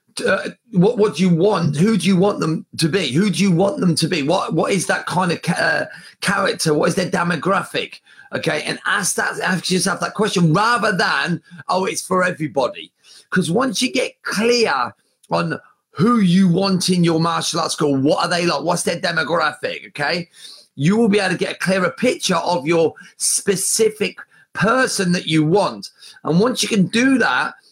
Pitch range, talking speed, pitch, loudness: 170-210 Hz, 195 wpm, 185 Hz, -18 LUFS